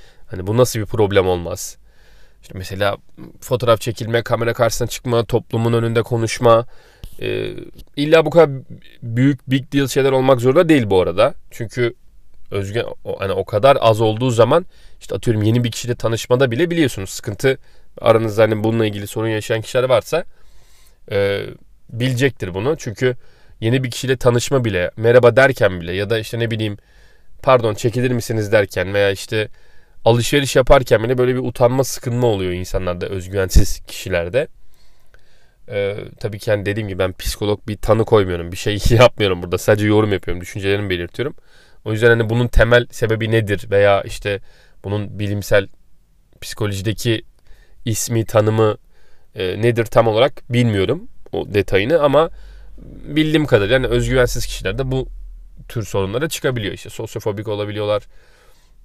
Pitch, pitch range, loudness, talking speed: 115 Hz, 100-125 Hz, -18 LUFS, 145 wpm